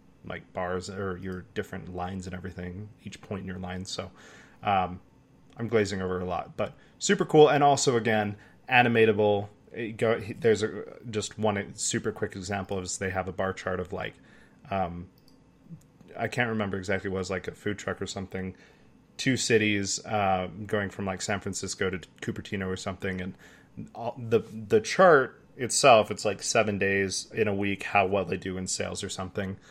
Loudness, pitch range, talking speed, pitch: -28 LUFS, 95-110 Hz, 180 wpm, 100 Hz